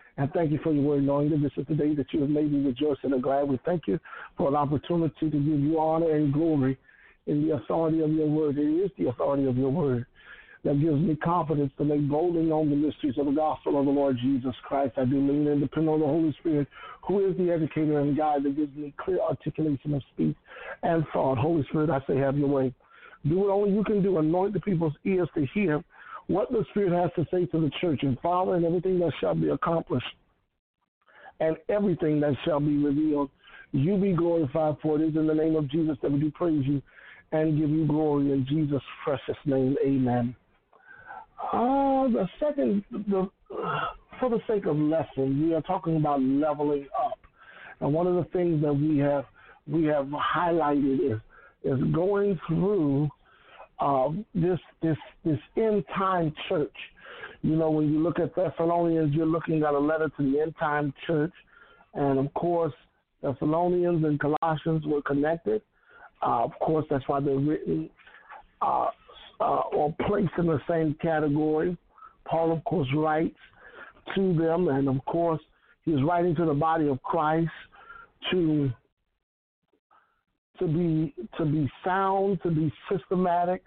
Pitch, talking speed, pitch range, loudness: 155 Hz, 185 wpm, 145-175 Hz, -27 LUFS